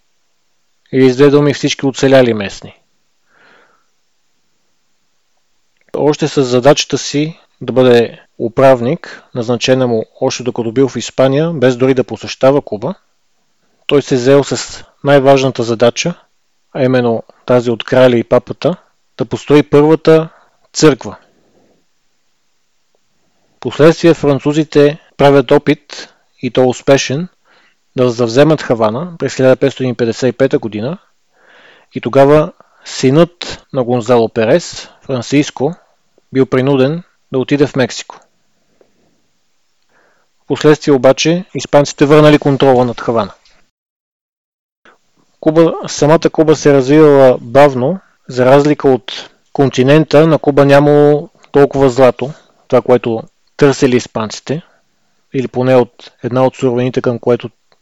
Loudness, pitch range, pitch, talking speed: -11 LUFS, 125-145 Hz, 135 Hz, 105 wpm